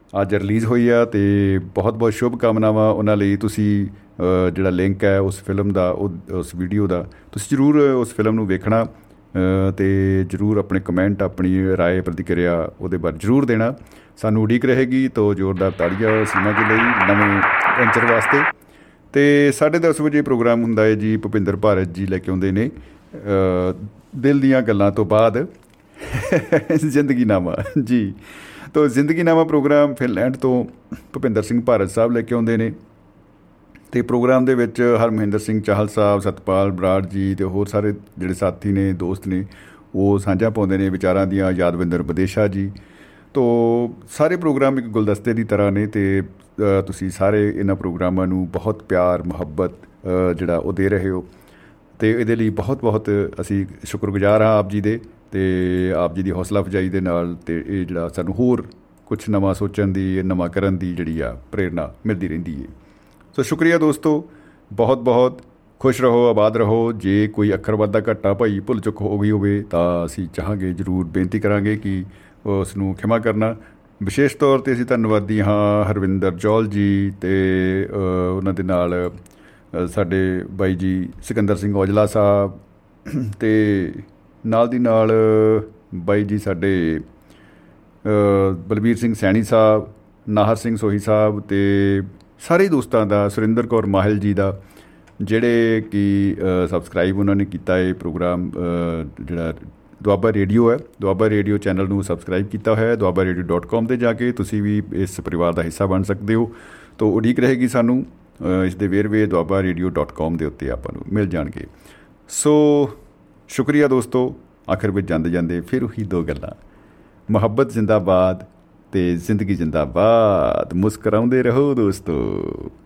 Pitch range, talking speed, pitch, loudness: 95-115 Hz, 155 wpm, 100 Hz, -19 LUFS